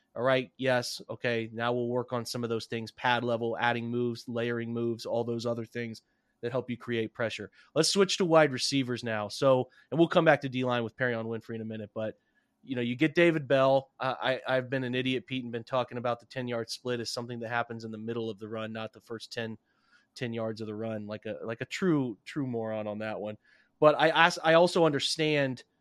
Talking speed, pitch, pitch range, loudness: 240 wpm, 120 Hz, 115-130 Hz, -30 LUFS